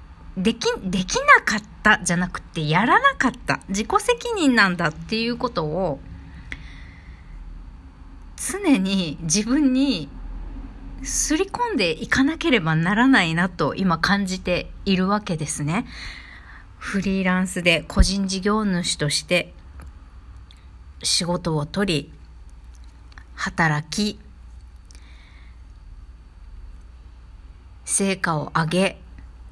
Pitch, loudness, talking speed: 165 Hz, -21 LUFS, 190 characters per minute